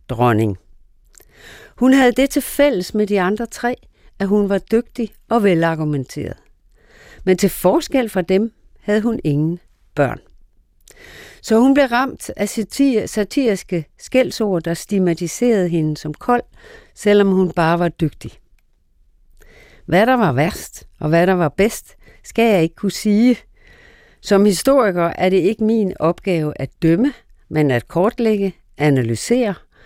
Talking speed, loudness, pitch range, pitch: 140 wpm, -17 LUFS, 165-225 Hz, 195 Hz